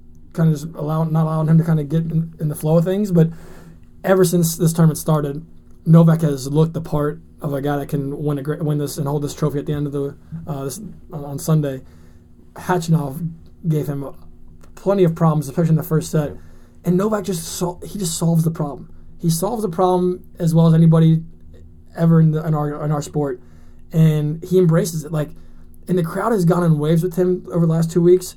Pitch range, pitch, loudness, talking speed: 145-170 Hz, 160 Hz, -19 LUFS, 220 wpm